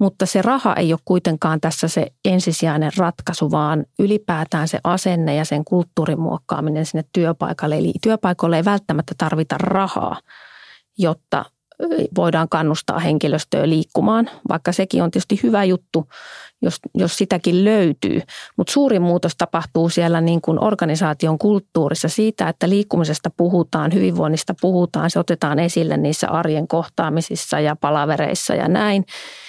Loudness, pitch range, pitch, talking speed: -19 LUFS, 160-185 Hz, 170 Hz, 130 wpm